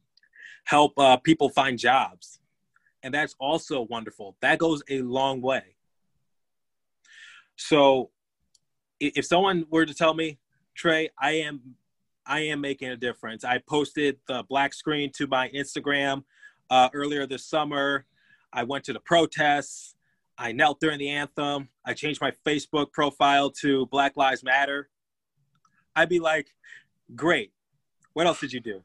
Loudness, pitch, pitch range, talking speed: -25 LUFS, 140 Hz, 135-150 Hz, 145 wpm